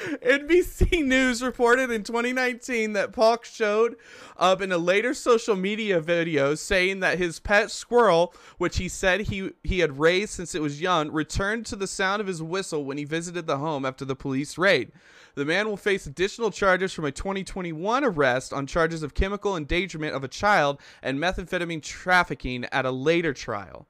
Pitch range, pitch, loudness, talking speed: 155-215 Hz, 185 Hz, -24 LUFS, 180 wpm